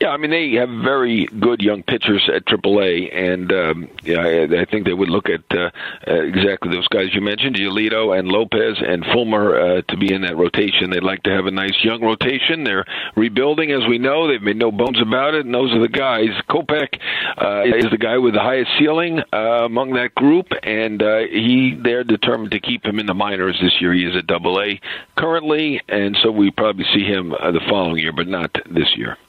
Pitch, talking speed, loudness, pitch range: 110 Hz, 225 wpm, -17 LUFS, 95-125 Hz